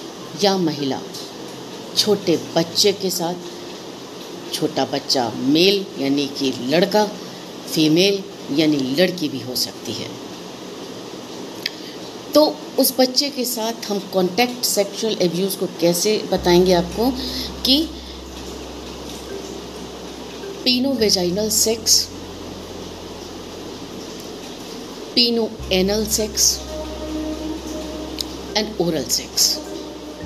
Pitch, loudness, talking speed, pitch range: 200 Hz, -19 LUFS, 85 wpm, 175-245 Hz